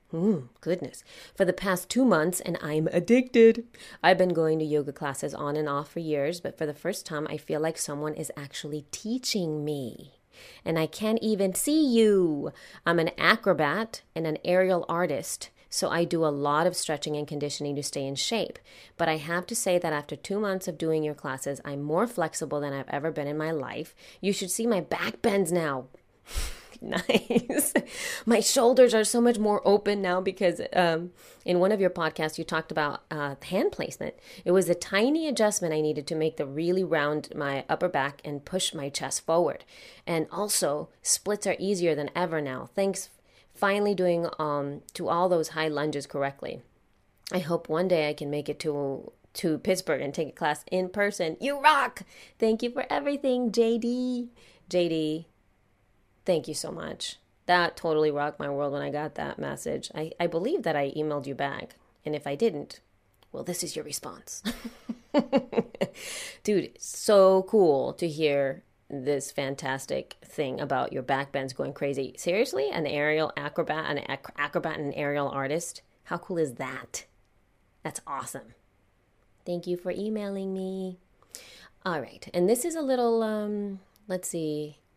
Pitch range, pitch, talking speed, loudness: 145-195 Hz, 165 Hz, 180 wpm, -28 LUFS